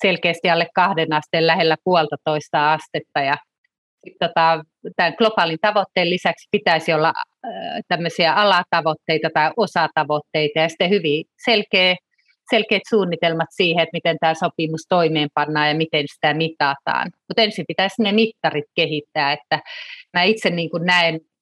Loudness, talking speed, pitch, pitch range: -19 LUFS, 130 wpm, 170 Hz, 160-195 Hz